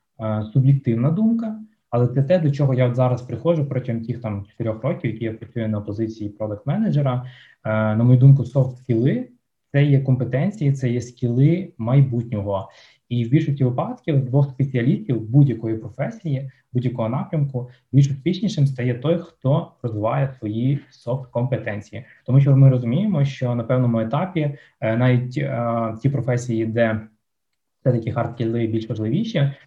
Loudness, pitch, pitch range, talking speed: -21 LUFS, 125 Hz, 115-140 Hz, 140 wpm